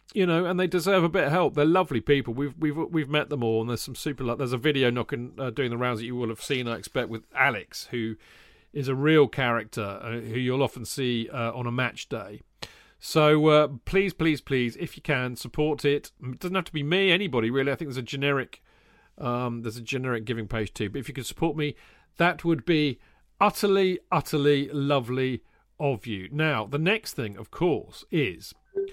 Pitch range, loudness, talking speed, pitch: 120-155 Hz, -26 LUFS, 220 wpm, 140 Hz